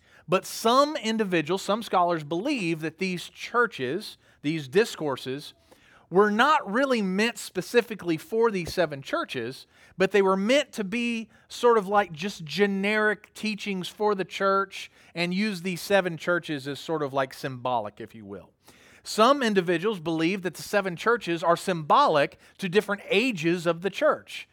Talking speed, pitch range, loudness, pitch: 155 wpm, 170-215 Hz, -26 LUFS, 190 Hz